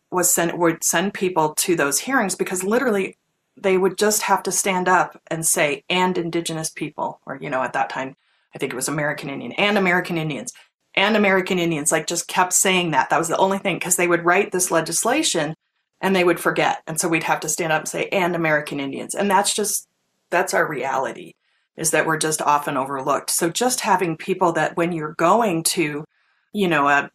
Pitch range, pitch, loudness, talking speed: 160-190 Hz, 175 Hz, -20 LUFS, 210 wpm